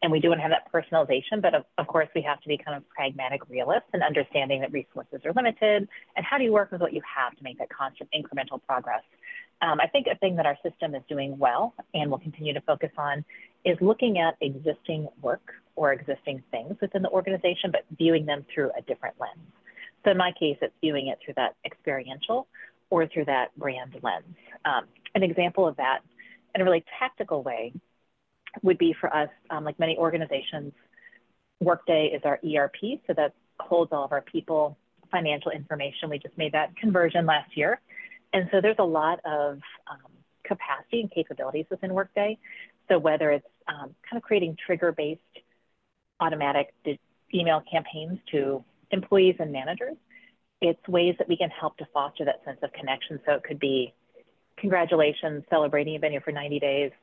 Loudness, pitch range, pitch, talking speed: -27 LUFS, 145-185 Hz, 160 Hz, 190 wpm